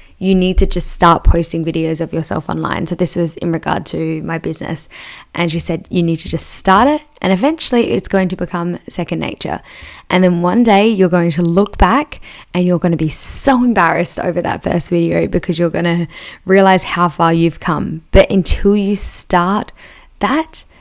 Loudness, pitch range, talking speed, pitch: -14 LUFS, 170-195 Hz, 200 wpm, 175 Hz